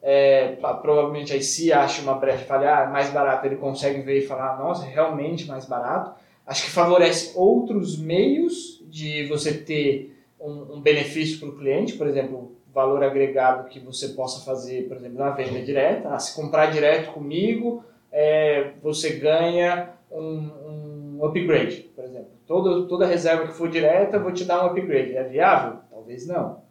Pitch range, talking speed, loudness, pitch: 135-165 Hz, 180 wpm, -22 LUFS, 150 Hz